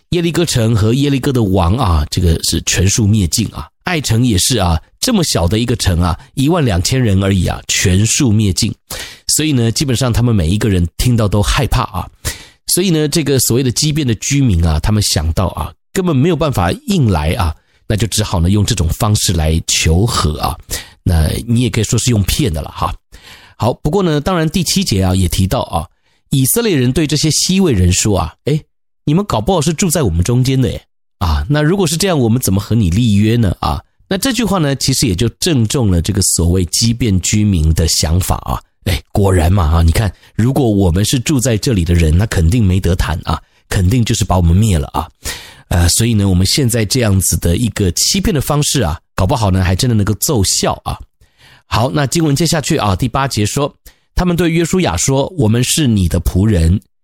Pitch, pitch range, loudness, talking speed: 110 Hz, 95-140 Hz, -14 LUFS, 305 characters per minute